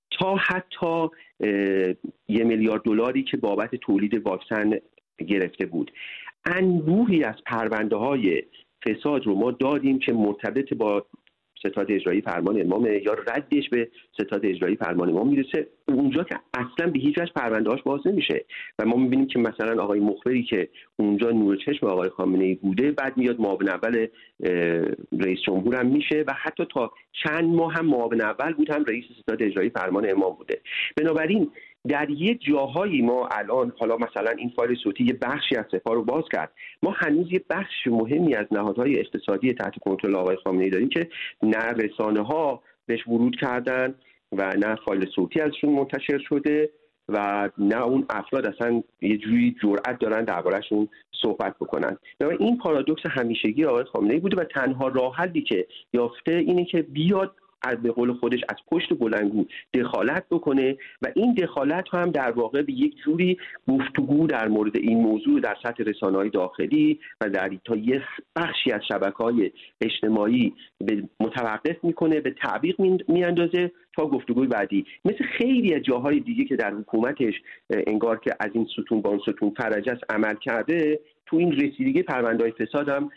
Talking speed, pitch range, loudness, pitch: 160 wpm, 110-165 Hz, -24 LUFS, 125 Hz